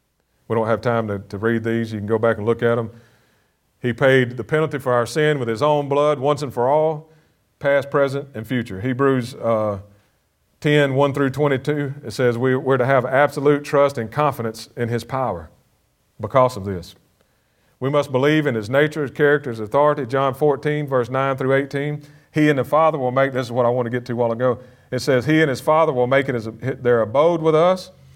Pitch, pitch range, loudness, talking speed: 130 Hz, 115-145 Hz, -20 LUFS, 225 wpm